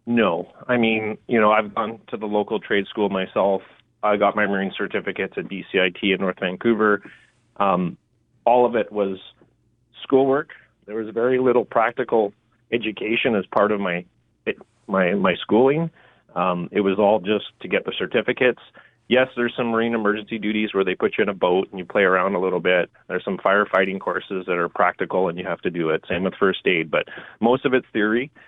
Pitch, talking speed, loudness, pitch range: 110 Hz, 200 wpm, -21 LUFS, 100-120 Hz